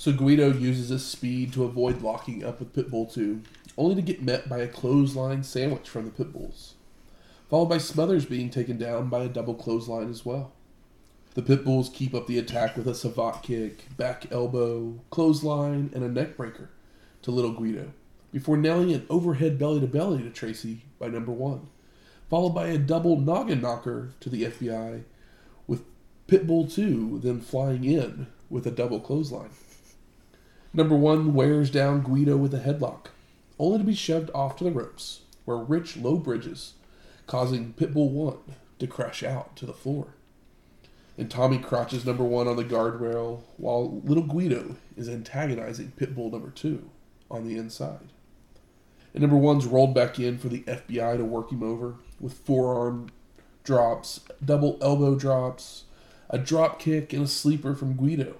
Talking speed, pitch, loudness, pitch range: 165 wpm, 130 Hz, -27 LUFS, 120-145 Hz